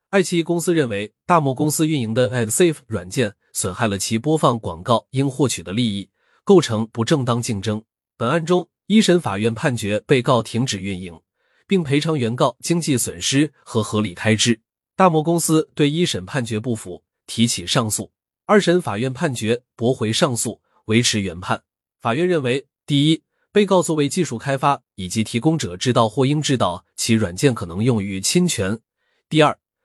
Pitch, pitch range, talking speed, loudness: 125 Hz, 110-155 Hz, 275 characters per minute, -20 LUFS